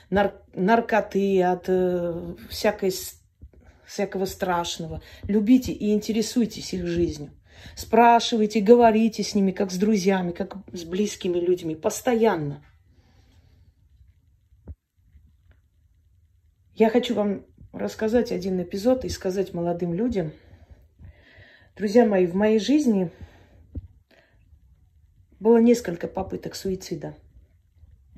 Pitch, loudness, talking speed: 180 Hz, -23 LUFS, 95 wpm